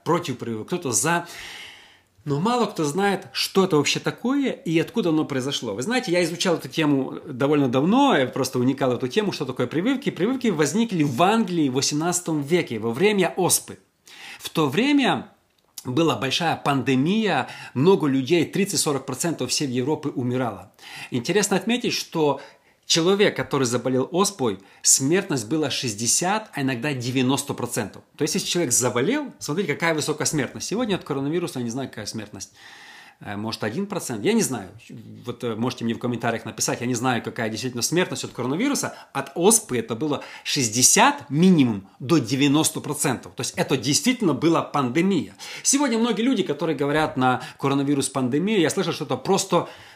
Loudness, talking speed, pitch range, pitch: -22 LUFS, 155 wpm, 130-175 Hz, 145 Hz